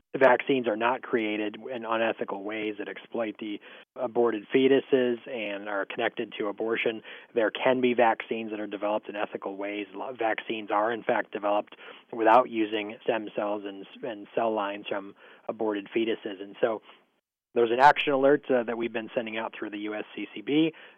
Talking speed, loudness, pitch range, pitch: 165 wpm, -28 LUFS, 105-120 Hz, 110 Hz